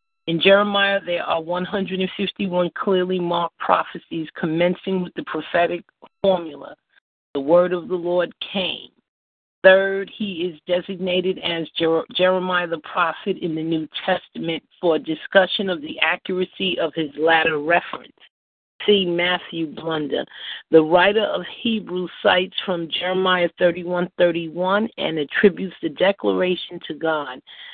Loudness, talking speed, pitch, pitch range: -21 LUFS, 140 wpm, 180 Hz, 165-190 Hz